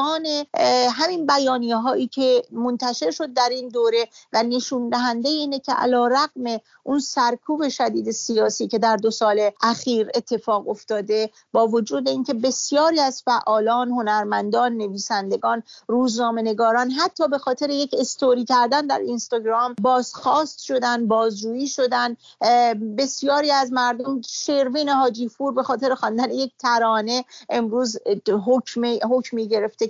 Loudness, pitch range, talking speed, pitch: -21 LUFS, 230-270 Hz, 125 wpm, 245 Hz